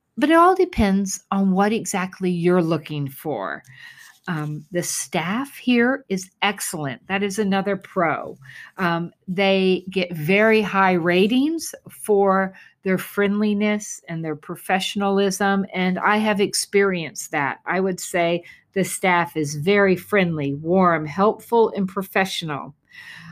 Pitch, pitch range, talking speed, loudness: 190 Hz, 175-205 Hz, 125 wpm, -21 LUFS